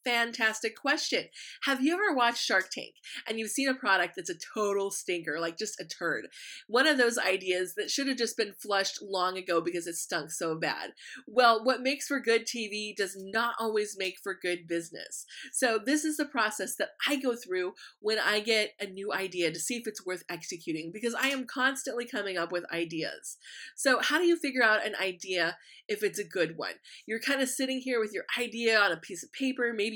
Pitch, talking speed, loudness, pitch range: 220 Hz, 215 wpm, -30 LUFS, 190-260 Hz